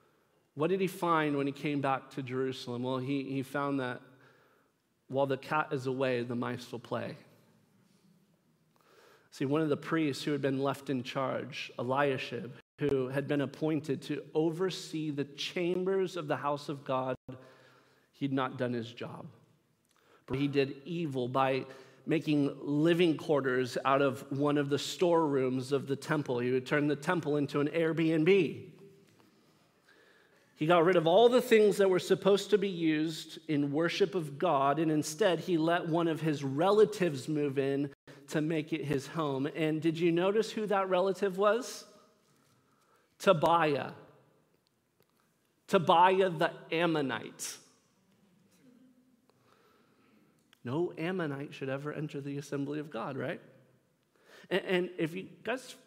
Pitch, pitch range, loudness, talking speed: 155 Hz, 140-180 Hz, -31 LUFS, 145 wpm